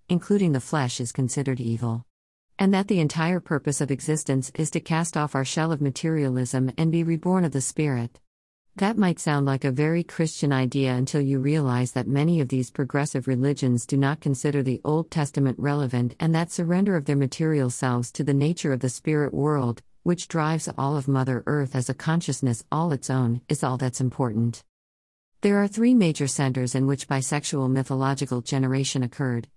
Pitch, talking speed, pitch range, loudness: 140 Hz, 185 wpm, 130-160 Hz, -25 LUFS